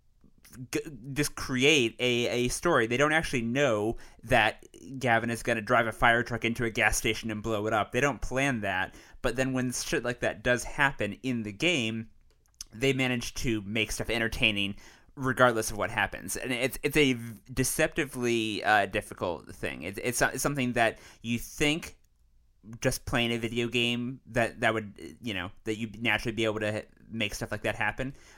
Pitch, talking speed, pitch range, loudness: 115 Hz, 185 wpm, 110-130 Hz, -28 LUFS